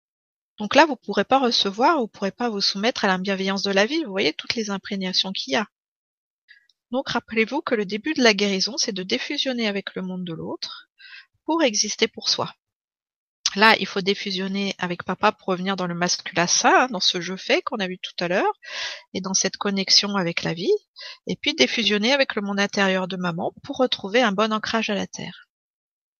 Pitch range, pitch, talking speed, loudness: 195-250 Hz, 210 Hz, 215 wpm, -22 LUFS